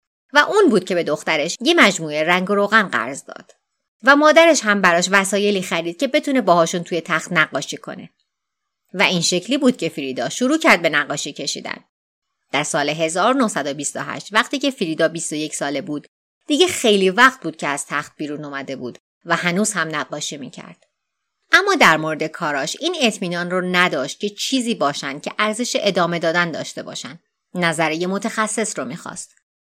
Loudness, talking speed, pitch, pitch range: -18 LUFS, 165 wpm, 180 Hz, 160-230 Hz